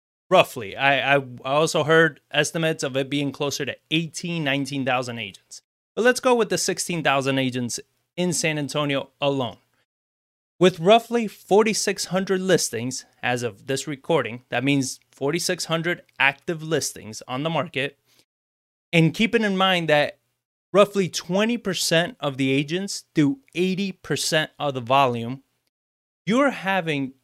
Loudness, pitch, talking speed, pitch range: -22 LUFS, 150 Hz, 130 wpm, 135-180 Hz